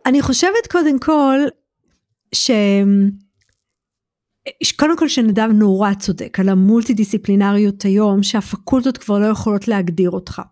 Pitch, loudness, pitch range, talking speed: 210 Hz, -15 LUFS, 200-265 Hz, 110 wpm